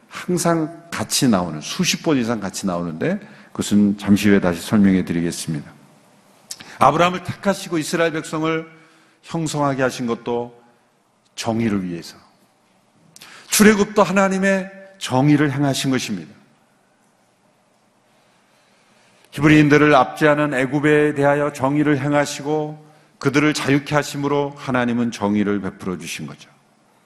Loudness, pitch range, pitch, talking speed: -19 LUFS, 110-160 Hz, 145 Hz, 290 characters per minute